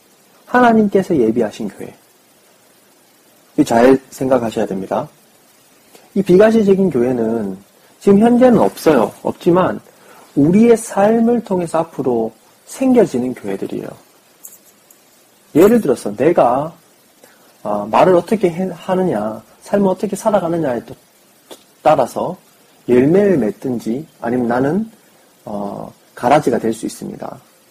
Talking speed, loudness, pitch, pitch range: 240 characters per minute, -15 LUFS, 175 Hz, 125-205 Hz